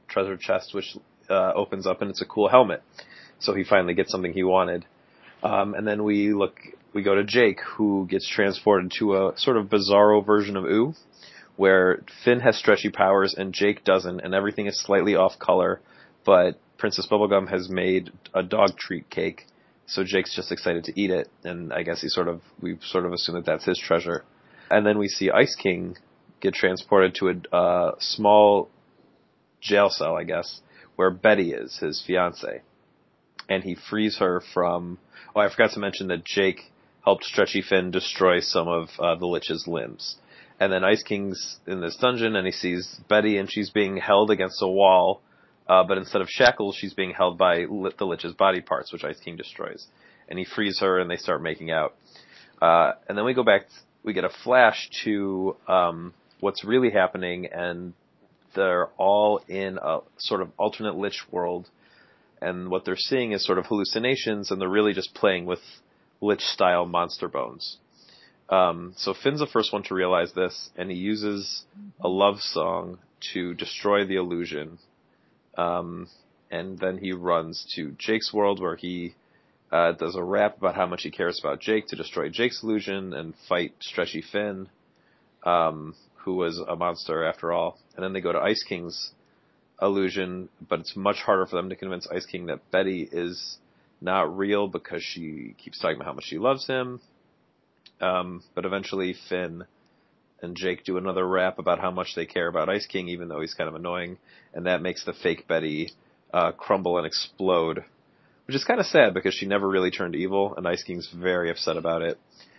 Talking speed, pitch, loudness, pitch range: 185 wpm, 95 Hz, -24 LUFS, 90-100 Hz